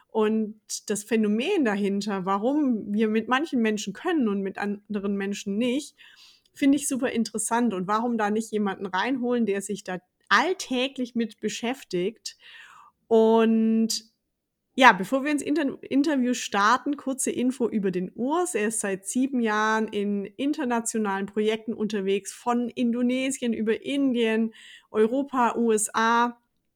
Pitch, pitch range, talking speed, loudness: 225 Hz, 210-255 Hz, 130 wpm, -25 LUFS